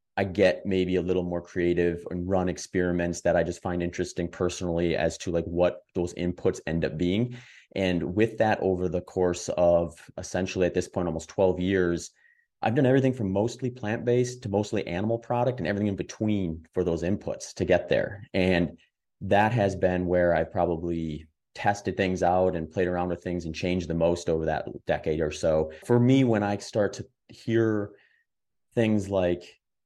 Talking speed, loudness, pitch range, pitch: 185 wpm, -27 LUFS, 85-105 Hz, 90 Hz